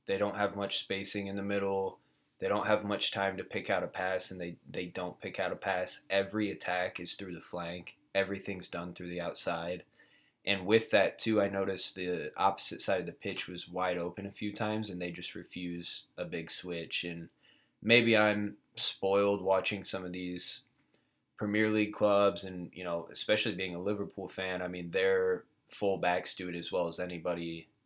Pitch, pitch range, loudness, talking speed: 95 Hz, 90-105 Hz, -33 LUFS, 200 wpm